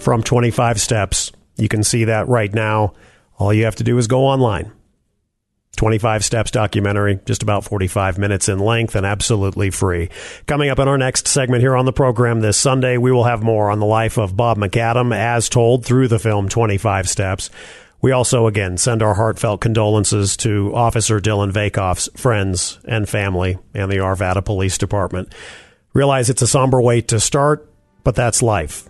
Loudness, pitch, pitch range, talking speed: -16 LUFS, 110 Hz, 100-120 Hz, 180 wpm